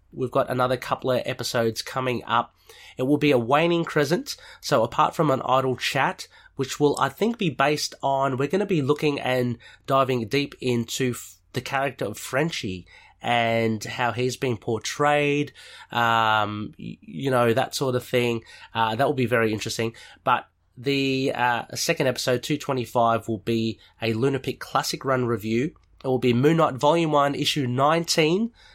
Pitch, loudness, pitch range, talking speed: 130 Hz, -24 LUFS, 115-145 Hz, 170 wpm